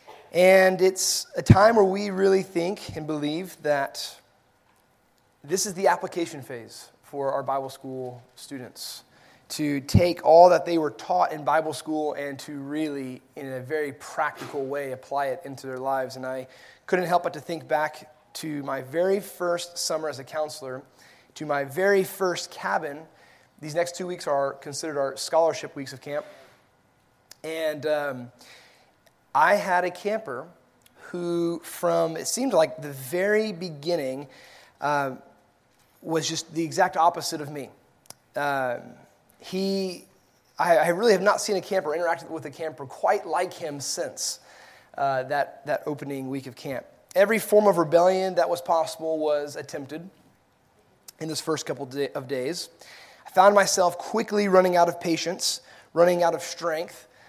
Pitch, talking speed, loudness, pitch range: 155 Hz, 160 wpm, -25 LUFS, 140-175 Hz